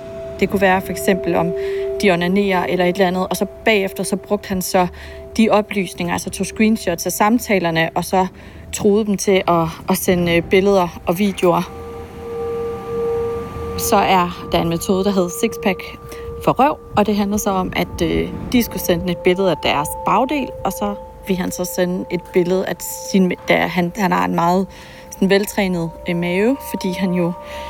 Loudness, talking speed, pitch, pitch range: -18 LUFS, 180 wpm, 185 Hz, 175-205 Hz